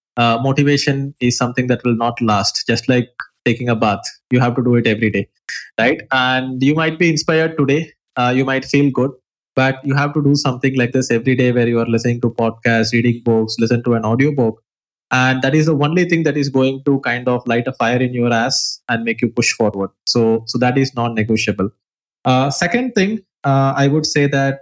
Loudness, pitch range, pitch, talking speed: -16 LUFS, 120-140 Hz, 125 Hz, 220 wpm